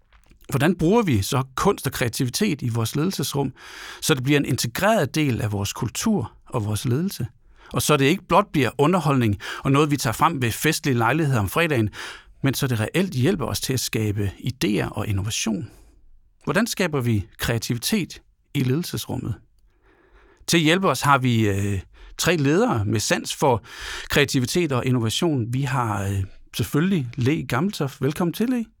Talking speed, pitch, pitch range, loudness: 170 wpm, 135 Hz, 115-155 Hz, -22 LUFS